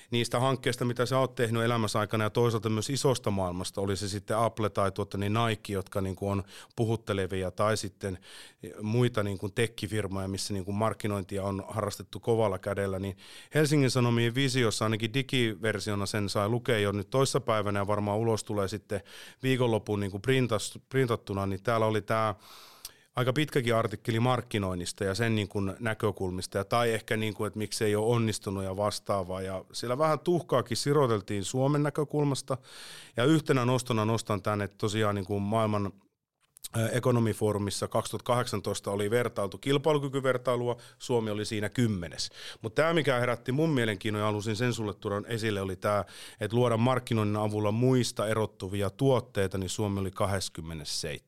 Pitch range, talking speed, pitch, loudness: 100-120 Hz, 160 wpm, 110 Hz, -30 LUFS